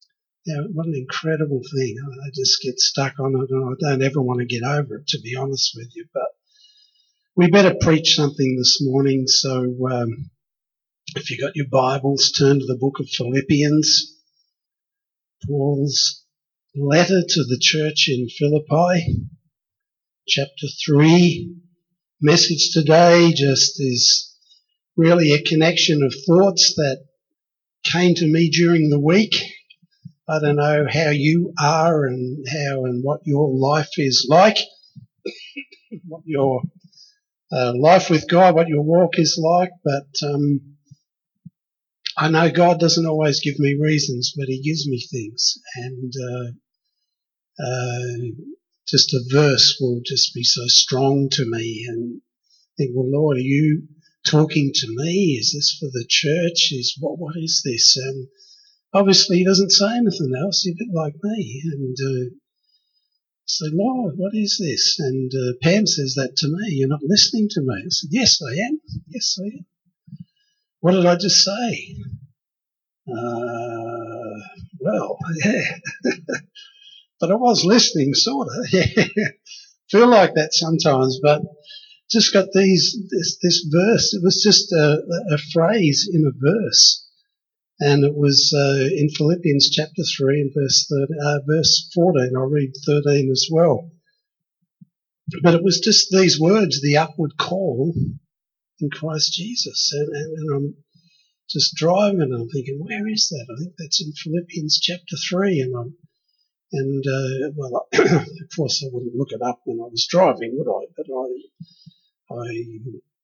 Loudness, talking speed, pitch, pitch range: -18 LUFS, 150 wpm, 155 Hz, 135-180 Hz